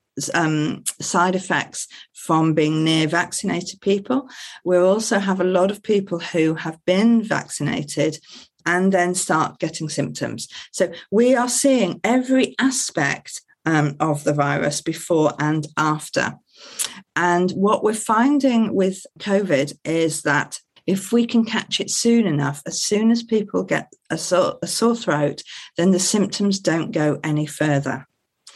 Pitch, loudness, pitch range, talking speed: 180 Hz, -20 LUFS, 155-210 Hz, 145 wpm